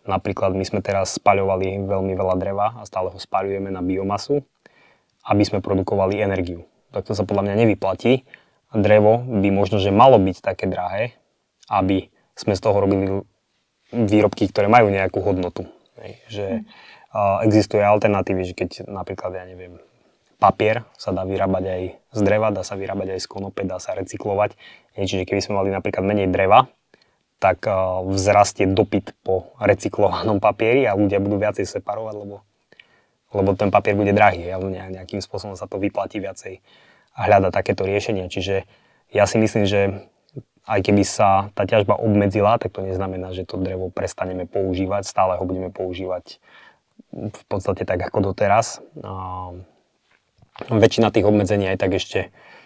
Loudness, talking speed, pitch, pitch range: -20 LUFS, 155 wpm, 100 Hz, 95-105 Hz